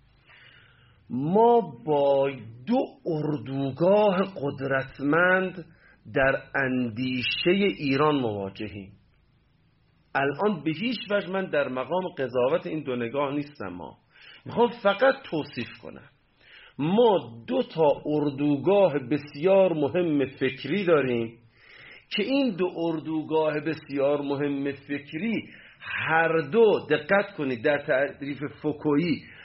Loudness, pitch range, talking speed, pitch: -25 LUFS, 135-180 Hz, 100 wpm, 145 Hz